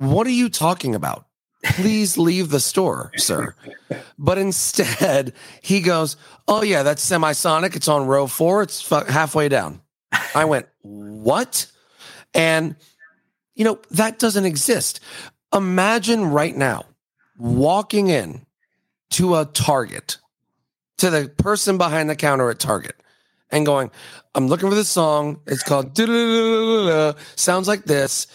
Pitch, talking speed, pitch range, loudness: 160 Hz, 135 wpm, 145-195 Hz, -19 LUFS